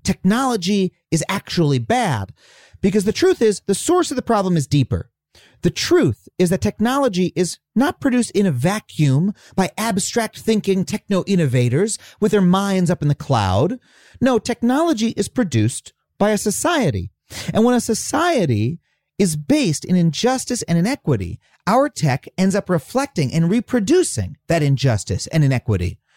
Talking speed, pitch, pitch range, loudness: 150 wpm, 195 Hz, 155-235 Hz, -19 LUFS